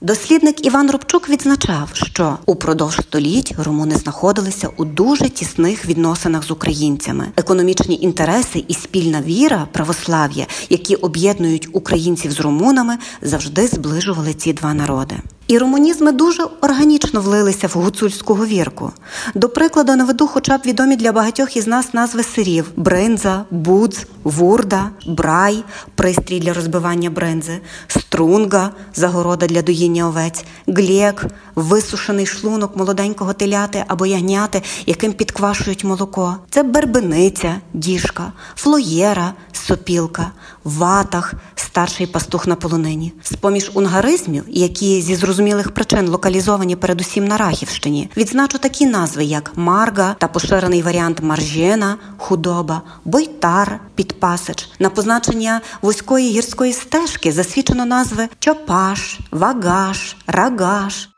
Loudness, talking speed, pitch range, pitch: -16 LUFS, 115 wpm, 170-220 Hz, 190 Hz